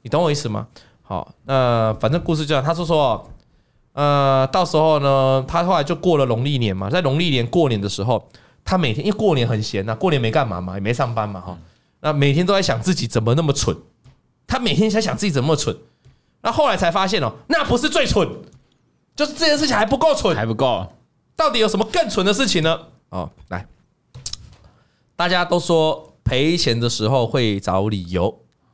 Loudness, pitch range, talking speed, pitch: -19 LUFS, 115-175 Hz, 290 characters per minute, 140 Hz